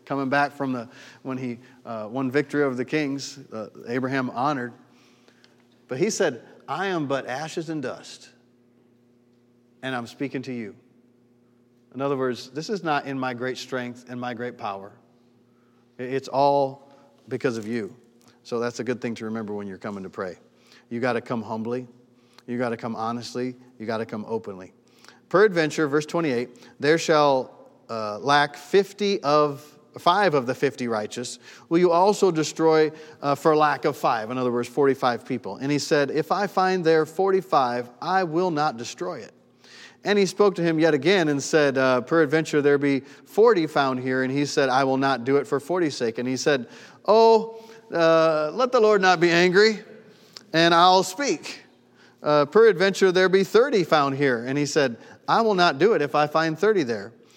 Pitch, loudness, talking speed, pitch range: 140 Hz, -23 LUFS, 185 wpm, 120-160 Hz